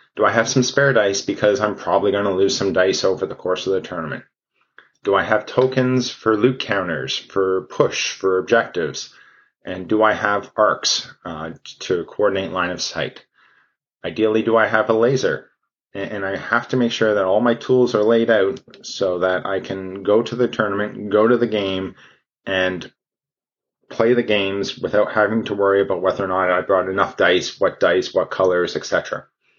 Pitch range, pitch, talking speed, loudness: 95-115 Hz, 105 Hz, 190 wpm, -19 LUFS